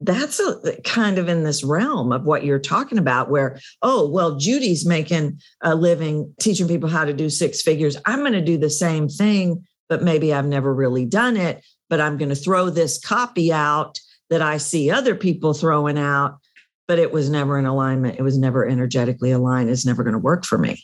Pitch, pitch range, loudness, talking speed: 155 Hz, 140-175 Hz, -20 LUFS, 210 wpm